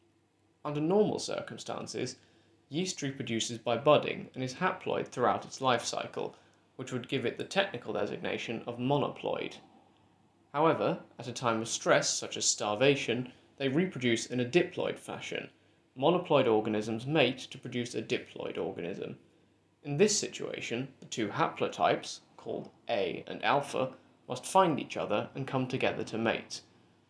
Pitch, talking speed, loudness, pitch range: 130 Hz, 145 wpm, -32 LUFS, 115-150 Hz